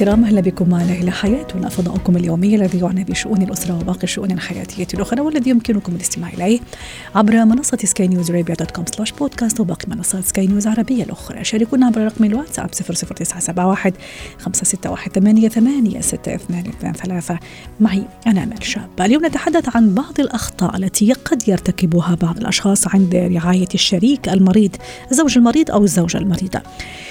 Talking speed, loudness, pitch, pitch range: 140 wpm, -16 LUFS, 195 Hz, 180-225 Hz